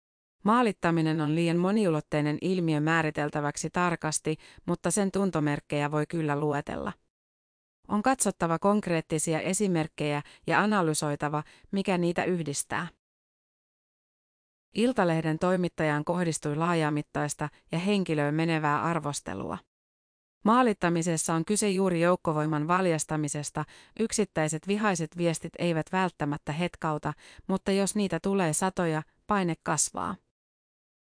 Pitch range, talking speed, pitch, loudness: 150-185 Hz, 95 wpm, 165 Hz, -28 LUFS